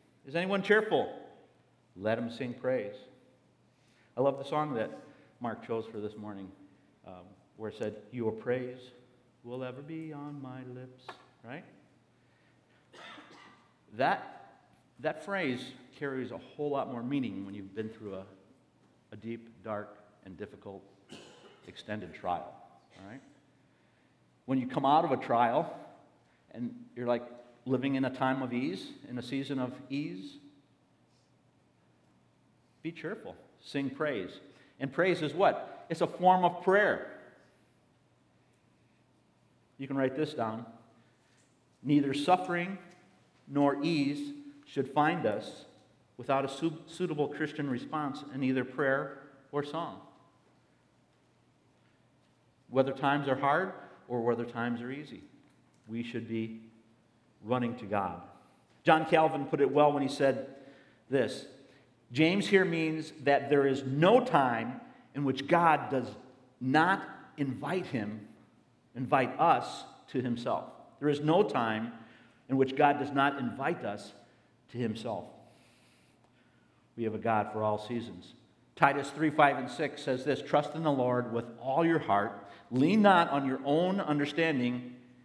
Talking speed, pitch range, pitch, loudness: 135 wpm, 115-145 Hz, 130 Hz, -31 LUFS